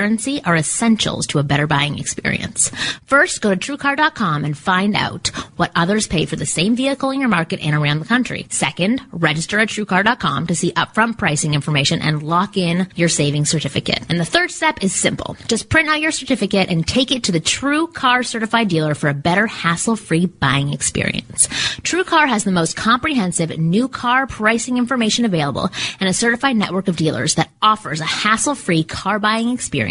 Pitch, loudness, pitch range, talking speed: 195 Hz, -17 LUFS, 160-240 Hz, 185 wpm